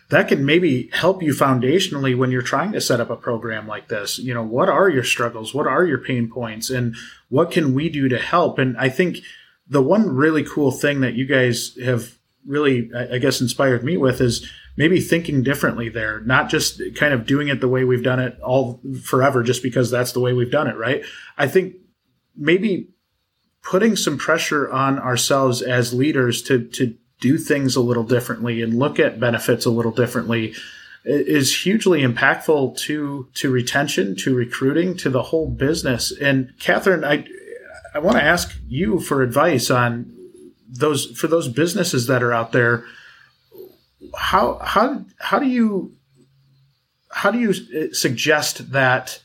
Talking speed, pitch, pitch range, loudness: 175 wpm, 130 Hz, 125-150 Hz, -19 LUFS